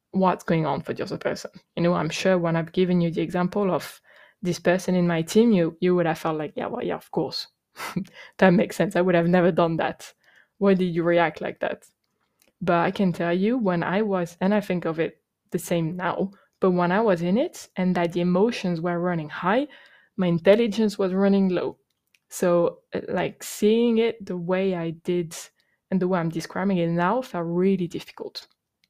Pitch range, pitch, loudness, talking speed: 175-195 Hz, 180 Hz, -24 LUFS, 210 wpm